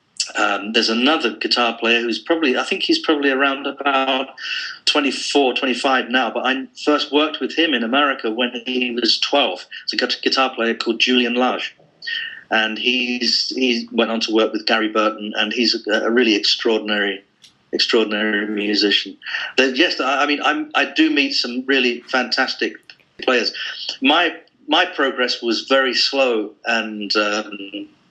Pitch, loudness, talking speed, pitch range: 120 Hz, -18 LUFS, 160 wpm, 110-135 Hz